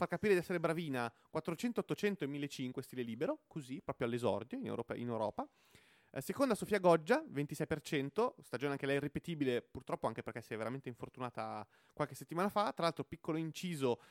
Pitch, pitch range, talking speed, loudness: 145 Hz, 130-175 Hz, 170 wpm, -39 LUFS